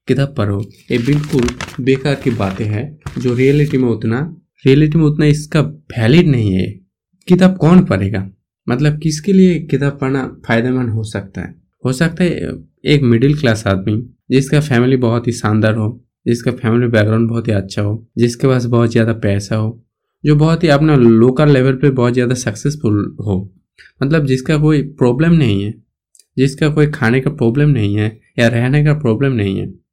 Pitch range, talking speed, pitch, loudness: 110-145 Hz, 175 wpm, 125 Hz, -14 LUFS